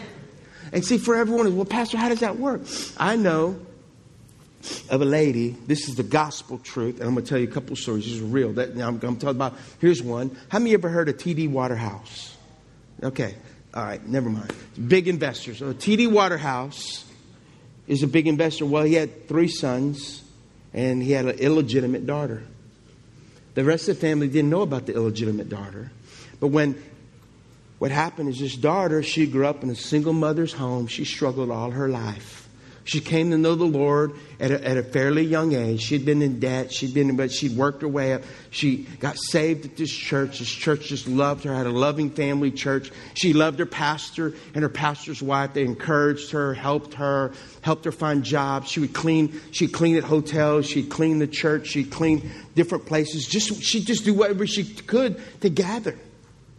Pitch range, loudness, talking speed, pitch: 130-160 Hz, -23 LUFS, 200 wpm, 145 Hz